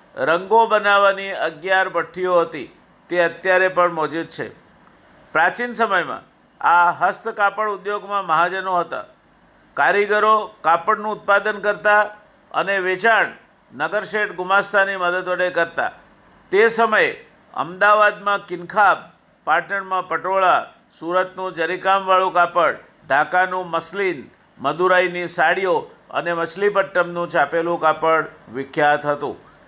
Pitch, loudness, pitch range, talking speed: 185 Hz, -19 LUFS, 175-205 Hz, 95 wpm